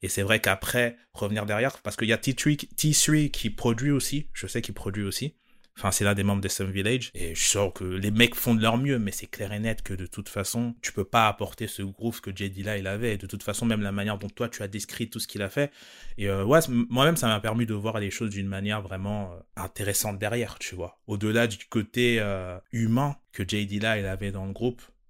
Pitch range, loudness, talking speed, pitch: 100-120 Hz, -27 LUFS, 250 wpm, 105 Hz